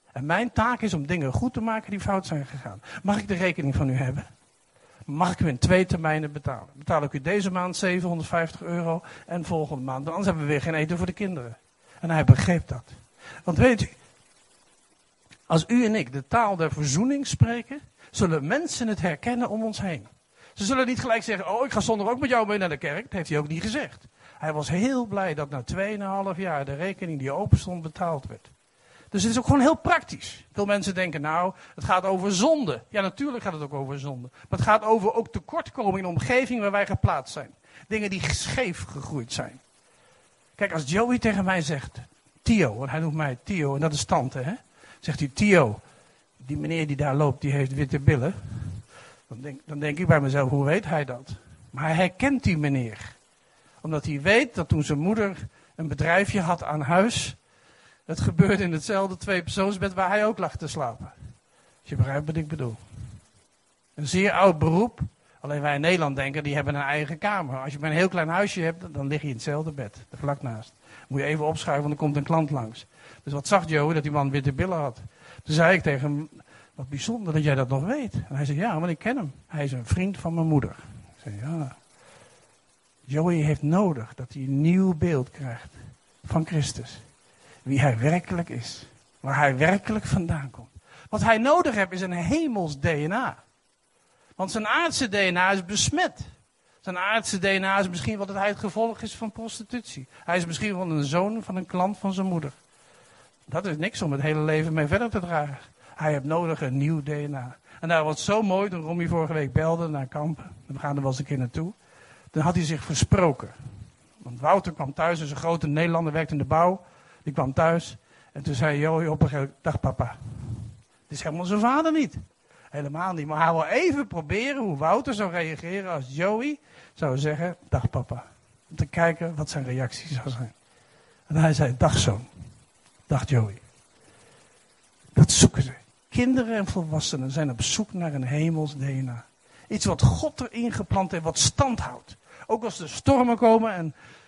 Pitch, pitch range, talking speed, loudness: 160 Hz, 140-190 Hz, 205 wpm, -25 LUFS